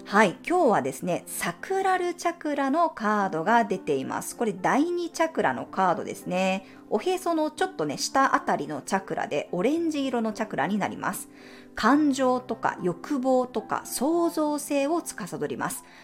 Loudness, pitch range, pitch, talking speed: -26 LUFS, 225-330 Hz, 275 Hz, 340 characters per minute